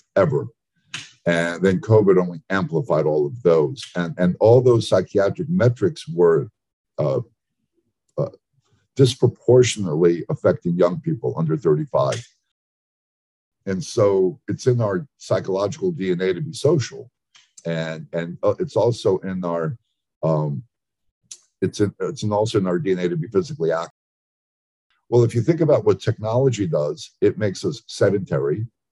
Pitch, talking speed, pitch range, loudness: 100 Hz, 135 wpm, 85-125 Hz, -21 LUFS